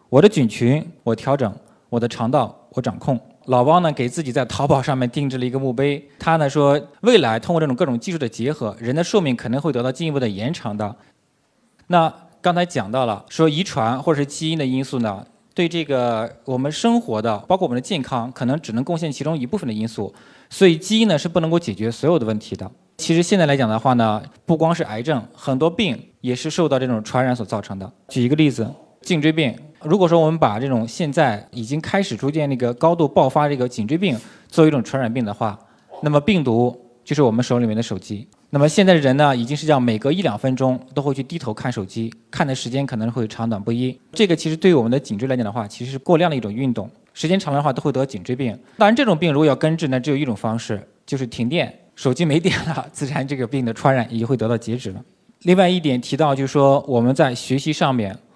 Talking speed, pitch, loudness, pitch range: 355 characters per minute, 135 Hz, -20 LUFS, 120-160 Hz